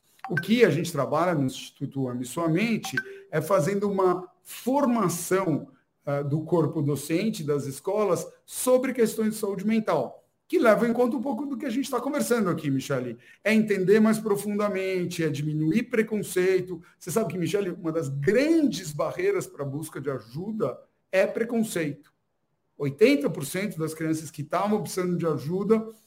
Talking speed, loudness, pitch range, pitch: 155 wpm, -26 LUFS, 155-220 Hz, 185 Hz